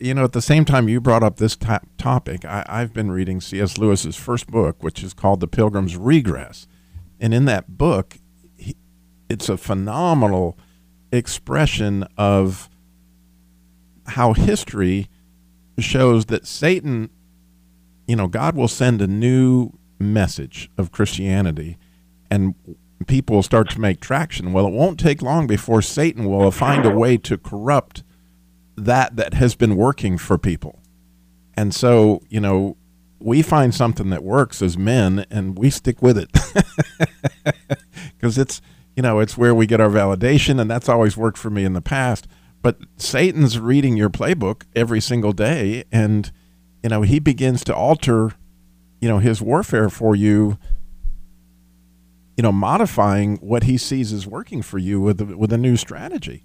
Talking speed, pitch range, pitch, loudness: 155 wpm, 90-125 Hz, 105 Hz, -18 LUFS